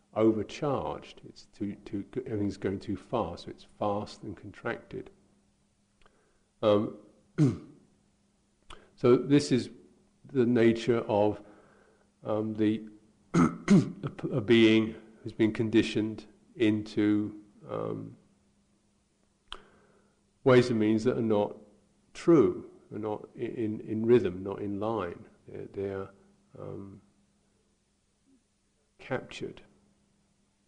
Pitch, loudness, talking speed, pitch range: 110 Hz, -29 LUFS, 95 wpm, 105-120 Hz